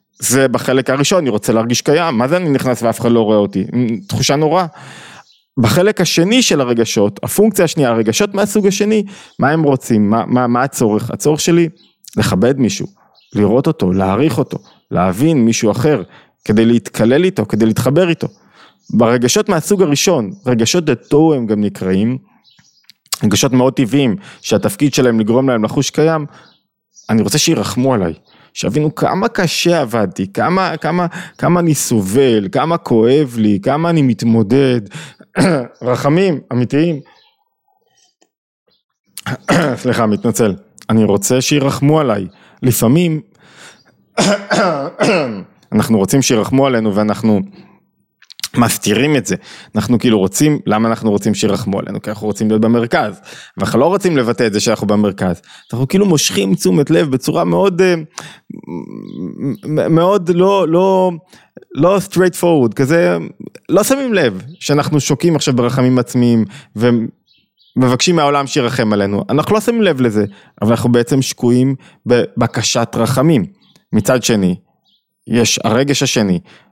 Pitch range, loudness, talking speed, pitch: 115-165 Hz, -14 LUFS, 130 wpm, 130 Hz